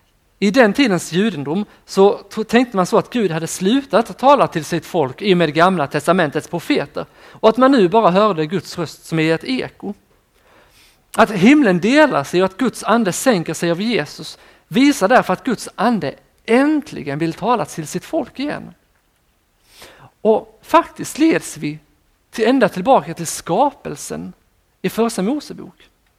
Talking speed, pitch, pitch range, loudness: 160 wpm, 195 Hz, 165-245 Hz, -17 LUFS